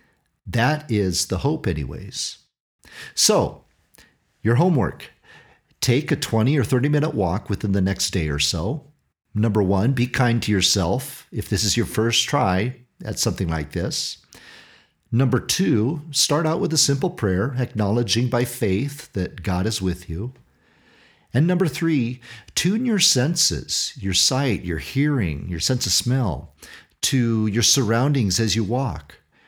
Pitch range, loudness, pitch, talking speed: 95-135 Hz, -21 LUFS, 115 Hz, 150 wpm